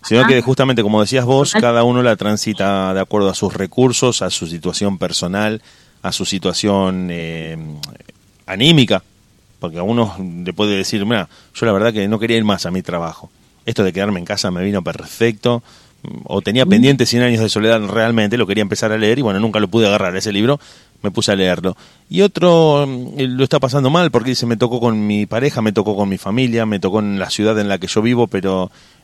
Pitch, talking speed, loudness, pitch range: 105 Hz, 215 wpm, -16 LUFS, 95-120 Hz